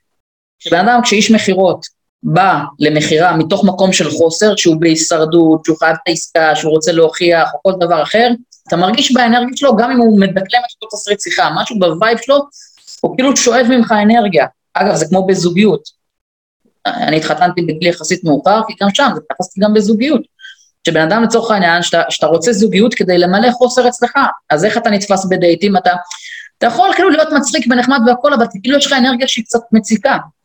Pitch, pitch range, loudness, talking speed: 205 Hz, 175-245 Hz, -11 LUFS, 170 wpm